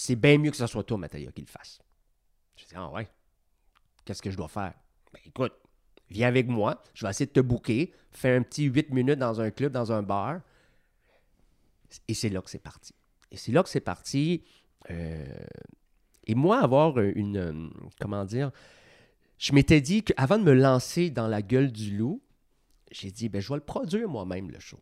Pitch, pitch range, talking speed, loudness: 120 Hz, 100-140 Hz, 200 wpm, -27 LUFS